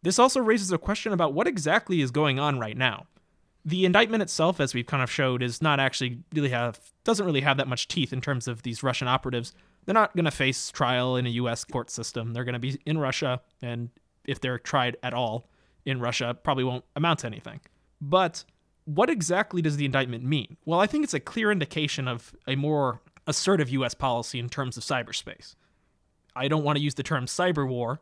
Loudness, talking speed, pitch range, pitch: -27 LUFS, 215 wpm, 125-160 Hz, 140 Hz